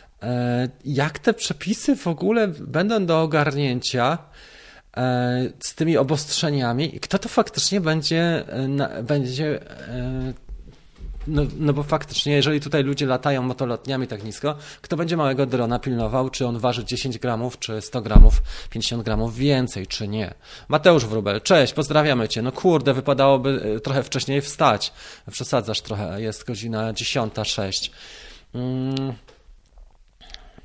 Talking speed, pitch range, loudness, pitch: 125 wpm, 120-150 Hz, -22 LUFS, 135 Hz